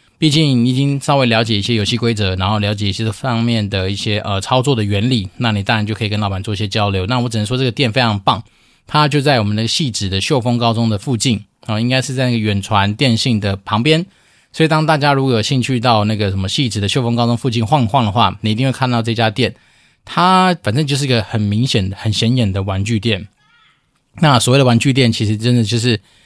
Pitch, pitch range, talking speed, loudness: 115 Hz, 105-130 Hz, 355 characters per minute, -15 LUFS